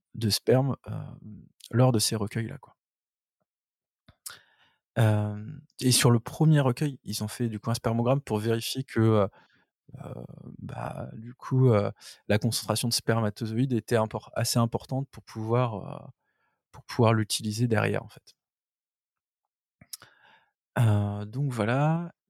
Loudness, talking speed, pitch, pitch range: -27 LUFS, 130 wpm, 115 Hz, 105-125 Hz